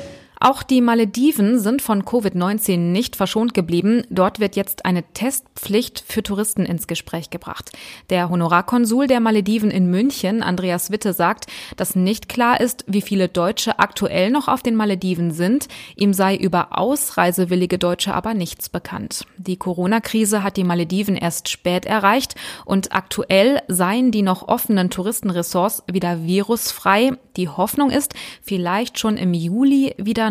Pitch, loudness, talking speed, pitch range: 200 Hz, -19 LUFS, 145 wpm, 180-230 Hz